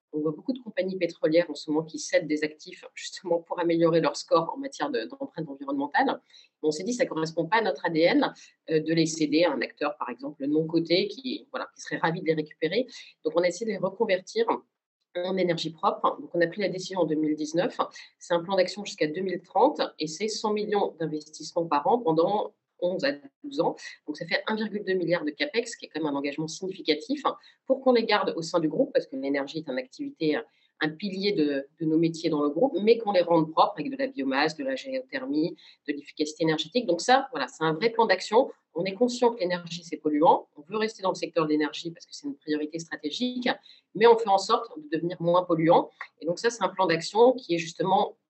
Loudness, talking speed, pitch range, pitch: -27 LUFS, 235 wpm, 160-240 Hz, 175 Hz